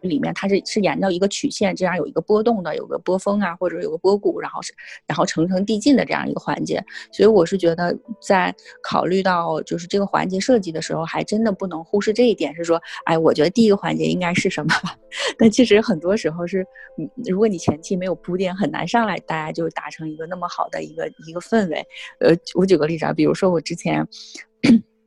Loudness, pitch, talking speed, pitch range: -20 LUFS, 190 Hz, 345 characters per minute, 170-220 Hz